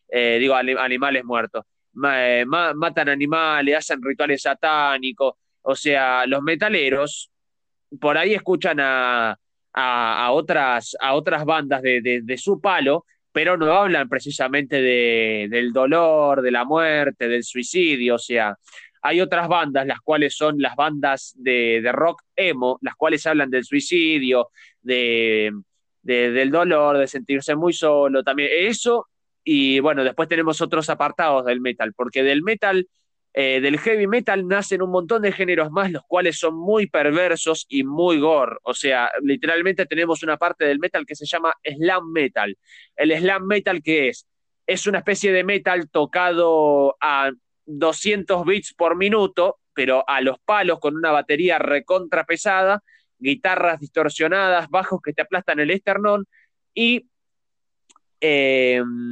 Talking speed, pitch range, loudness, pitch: 150 wpm, 135-180 Hz, -20 LUFS, 155 Hz